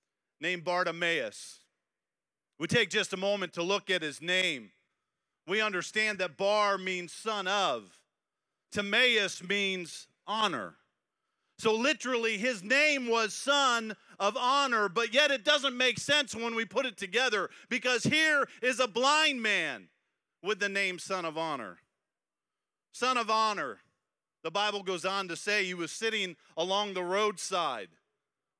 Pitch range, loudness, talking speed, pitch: 185-250 Hz, -29 LUFS, 145 wpm, 210 Hz